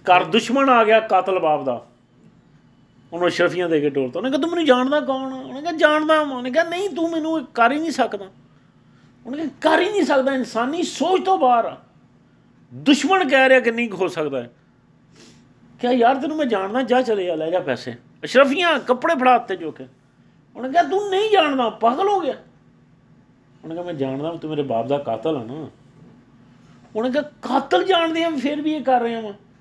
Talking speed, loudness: 195 wpm, -19 LUFS